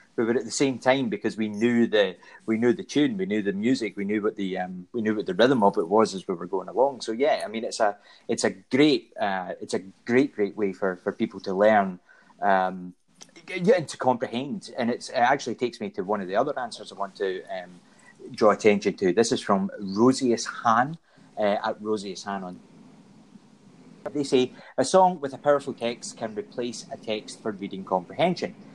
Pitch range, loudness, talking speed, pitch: 100-130 Hz, -25 LUFS, 215 wpm, 115 Hz